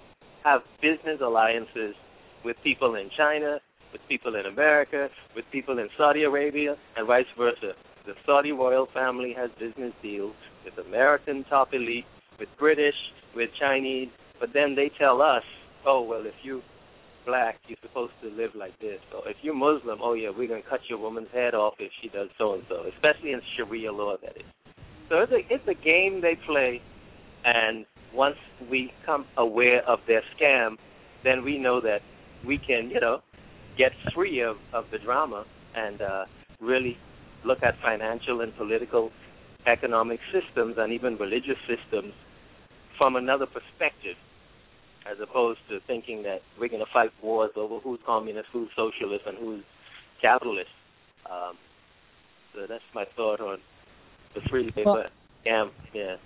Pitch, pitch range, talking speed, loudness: 125 Hz, 115-145 Hz, 160 wpm, -26 LUFS